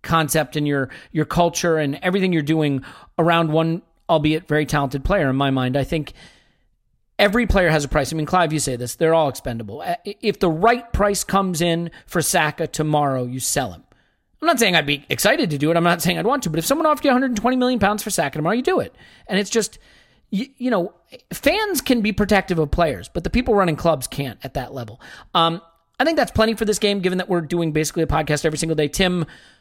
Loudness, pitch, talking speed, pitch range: -20 LUFS, 165 Hz, 235 wpm, 150-200 Hz